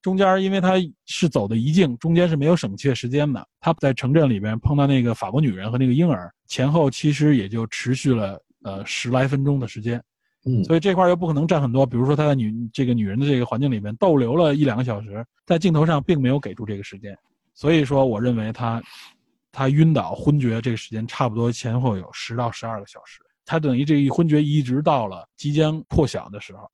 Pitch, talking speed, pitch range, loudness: 135 Hz, 345 characters per minute, 115-150 Hz, -21 LUFS